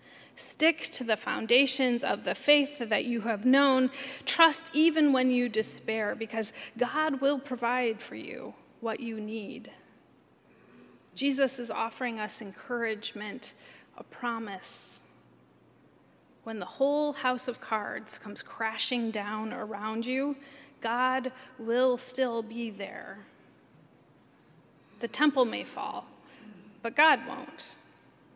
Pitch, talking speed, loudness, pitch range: 245 Hz, 115 wpm, -29 LUFS, 225-270 Hz